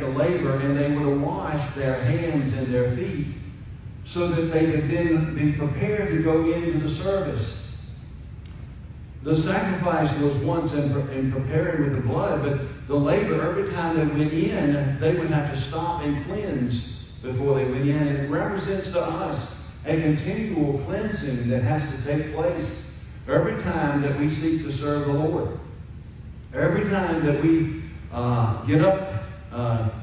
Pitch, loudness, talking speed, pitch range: 145 Hz, -24 LUFS, 160 wpm, 135-160 Hz